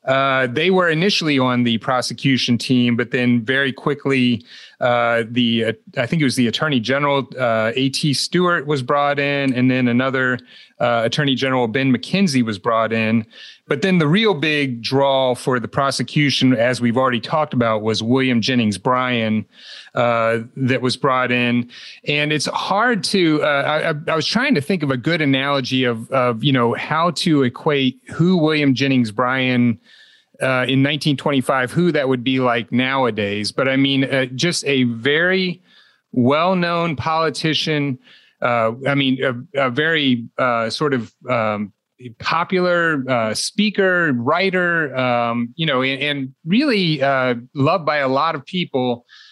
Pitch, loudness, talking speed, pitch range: 130 Hz, -18 LUFS, 160 wpm, 120-150 Hz